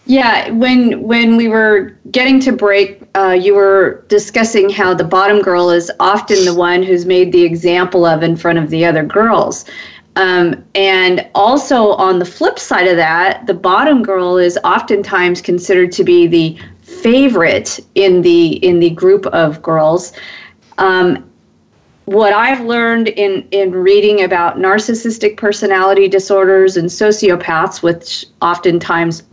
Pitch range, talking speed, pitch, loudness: 175-210 Hz, 145 wpm, 190 Hz, -11 LUFS